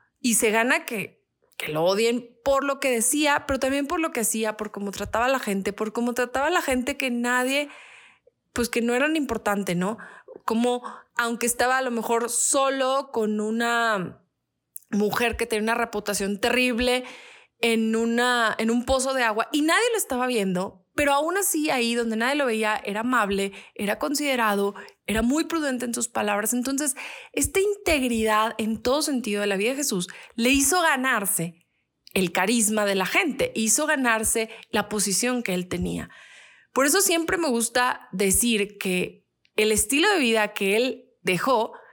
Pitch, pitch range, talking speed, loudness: 235 Hz, 215-270 Hz, 175 wpm, -23 LUFS